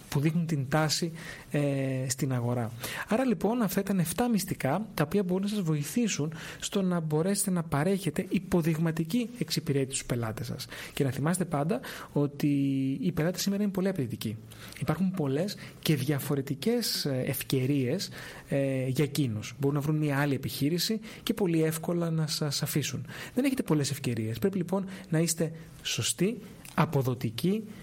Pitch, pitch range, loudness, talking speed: 155 Hz, 140-185 Hz, -30 LUFS, 150 wpm